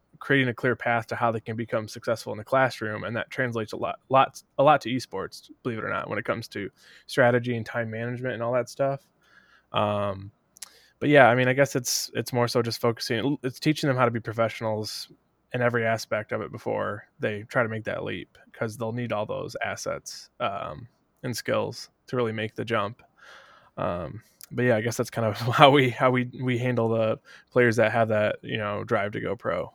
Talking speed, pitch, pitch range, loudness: 220 wpm, 120 Hz, 110-125 Hz, -26 LUFS